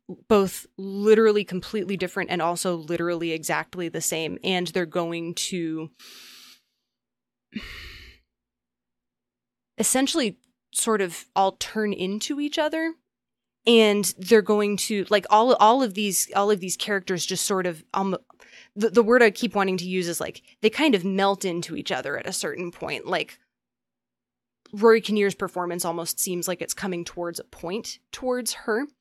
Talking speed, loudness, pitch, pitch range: 155 wpm, -24 LUFS, 195 Hz, 175-215 Hz